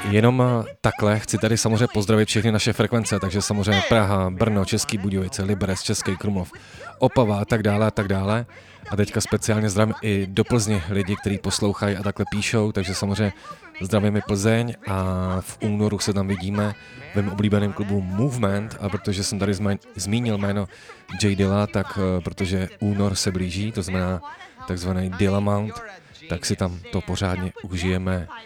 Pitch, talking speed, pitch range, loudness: 100 Hz, 160 wpm, 95-110 Hz, -23 LUFS